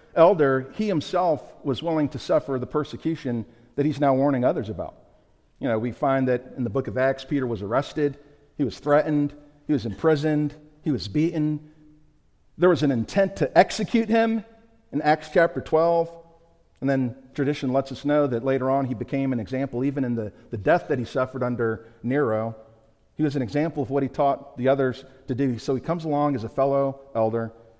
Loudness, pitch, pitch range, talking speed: -24 LUFS, 140 Hz, 125-150 Hz, 195 wpm